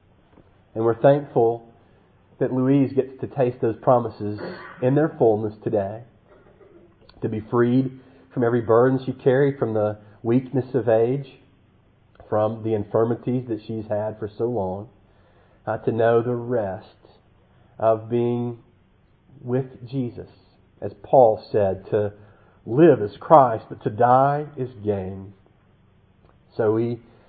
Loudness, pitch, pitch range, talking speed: -22 LUFS, 115 Hz, 105-125 Hz, 130 wpm